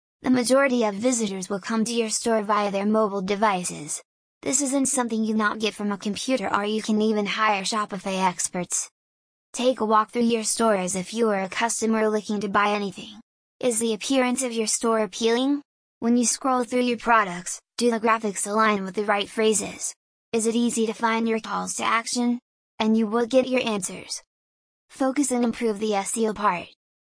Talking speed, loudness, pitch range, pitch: 195 wpm, -24 LUFS, 210-235 Hz, 220 Hz